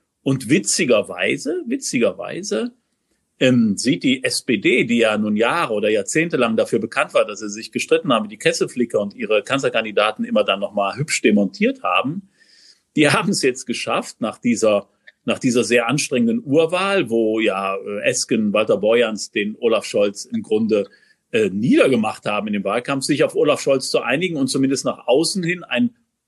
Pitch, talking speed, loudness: 135 Hz, 170 wpm, -19 LUFS